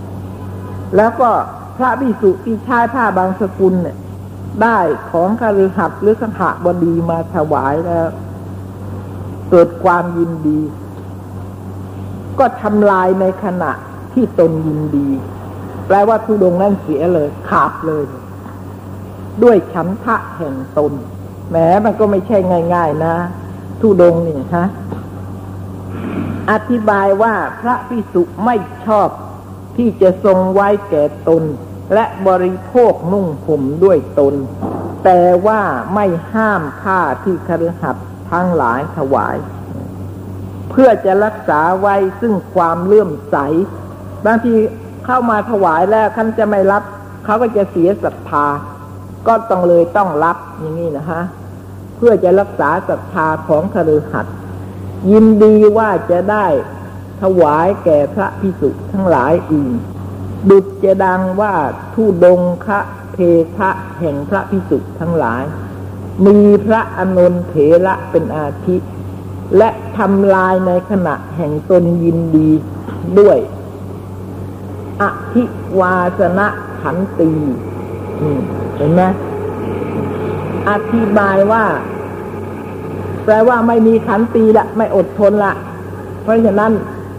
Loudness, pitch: -13 LUFS, 170 Hz